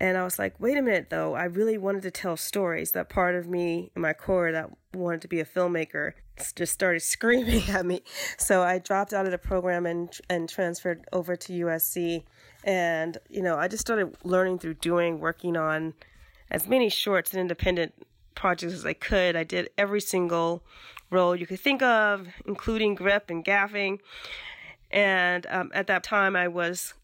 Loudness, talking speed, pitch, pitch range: -27 LUFS, 190 wpm, 180 Hz, 170-195 Hz